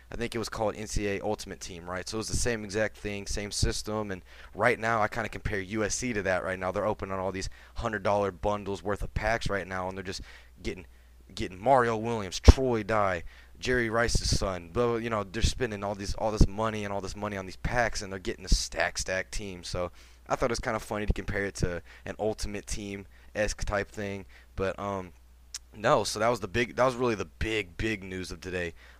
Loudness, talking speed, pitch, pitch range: -30 LUFS, 230 wpm, 100 Hz, 90-110 Hz